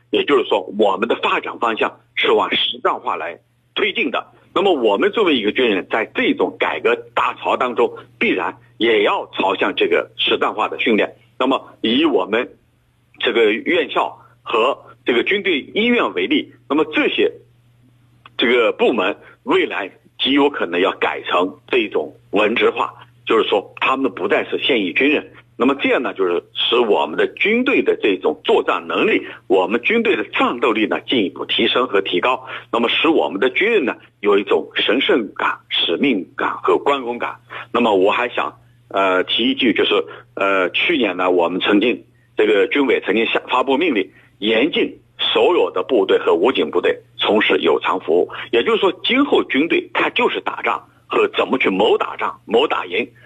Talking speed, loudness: 265 characters per minute, -17 LUFS